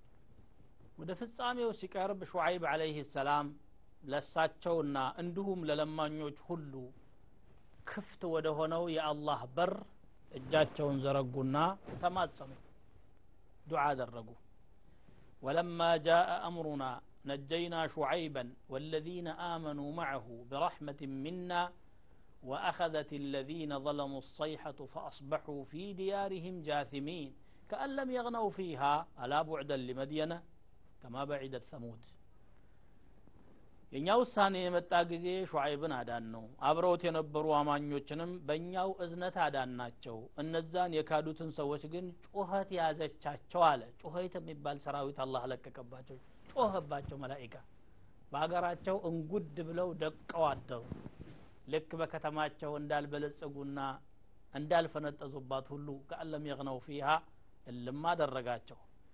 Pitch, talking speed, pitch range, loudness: 150 Hz, 90 wpm, 135-170 Hz, -37 LUFS